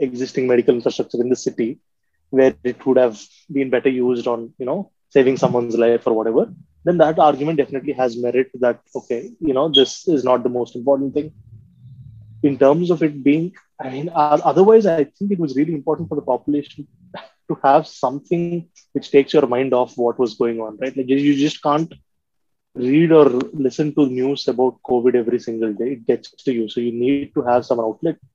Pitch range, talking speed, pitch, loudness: 125-150 Hz, 200 wpm, 130 Hz, -18 LUFS